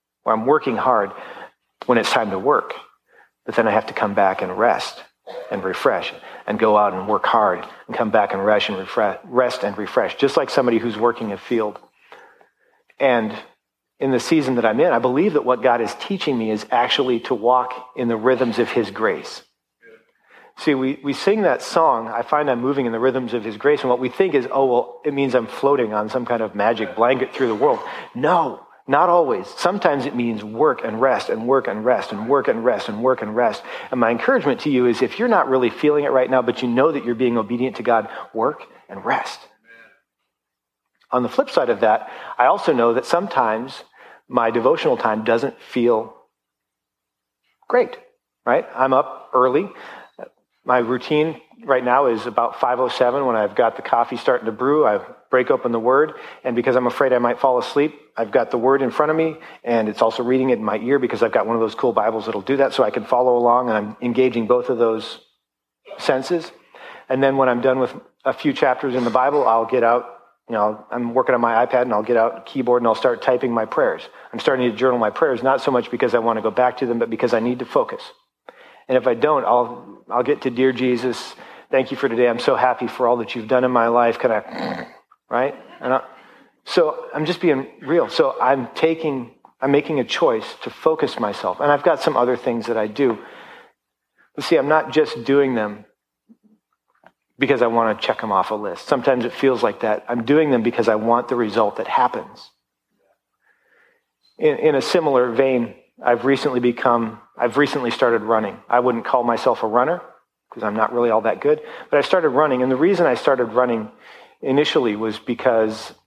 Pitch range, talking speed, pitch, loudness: 115-145 Hz, 215 wpm, 125 Hz, -19 LUFS